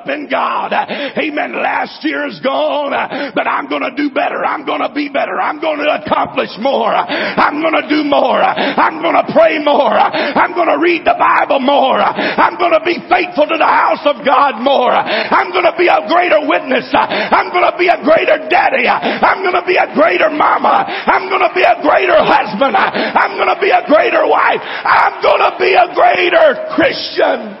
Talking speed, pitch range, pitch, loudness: 175 wpm, 295-350 Hz, 325 Hz, -12 LUFS